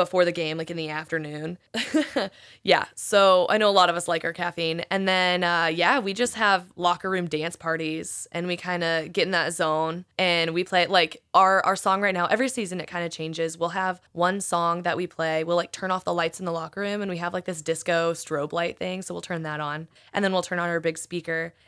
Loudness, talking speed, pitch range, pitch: -25 LUFS, 250 wpm, 165-185 Hz, 175 Hz